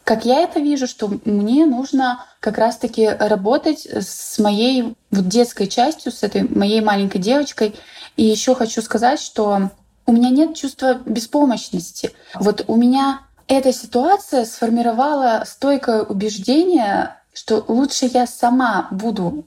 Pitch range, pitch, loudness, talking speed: 215-270 Hz, 240 Hz, -18 LUFS, 130 wpm